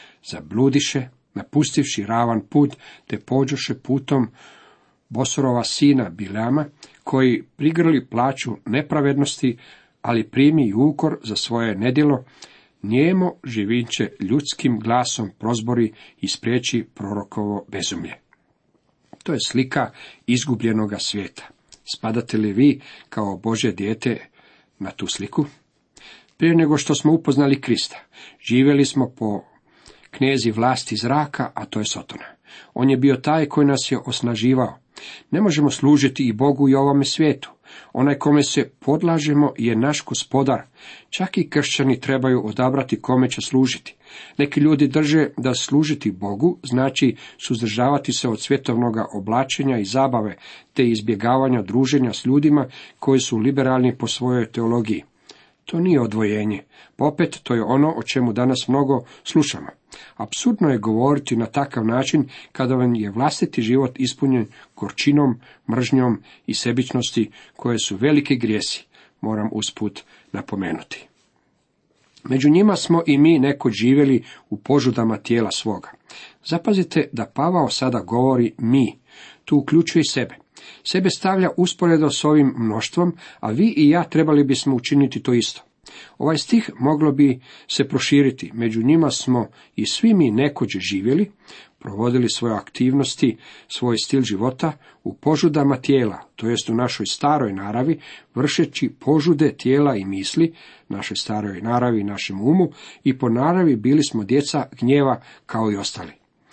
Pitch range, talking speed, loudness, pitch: 115-145 Hz, 135 wpm, -20 LUFS, 130 Hz